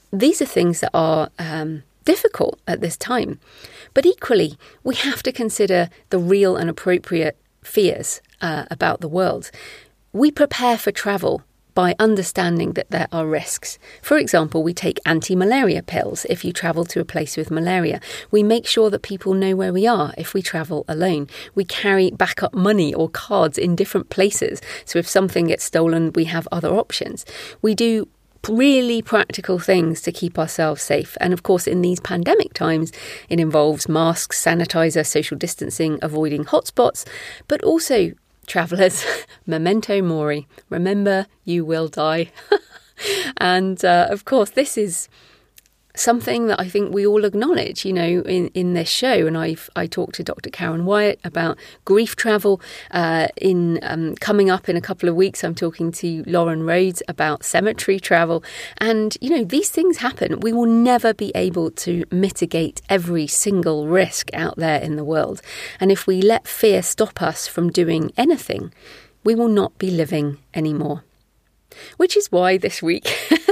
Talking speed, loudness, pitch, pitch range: 165 wpm, -19 LUFS, 185 Hz, 165-215 Hz